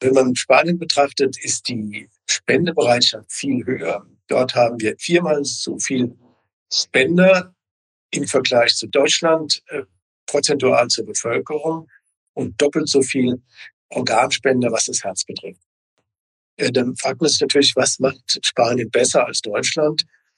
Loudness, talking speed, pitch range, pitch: -18 LUFS, 135 wpm, 120-155 Hz, 130 Hz